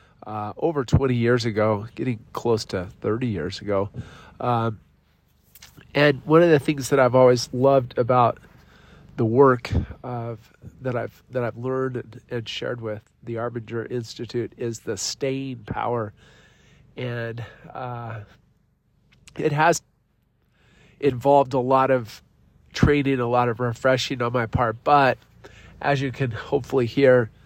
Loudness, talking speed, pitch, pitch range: -23 LUFS, 135 wpm, 120 Hz, 115-130 Hz